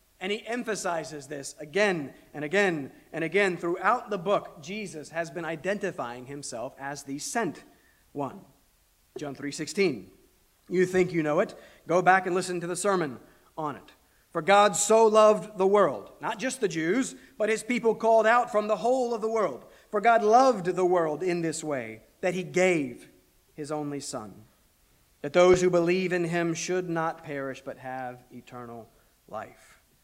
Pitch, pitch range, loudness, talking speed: 180 Hz, 150-205 Hz, -26 LUFS, 170 wpm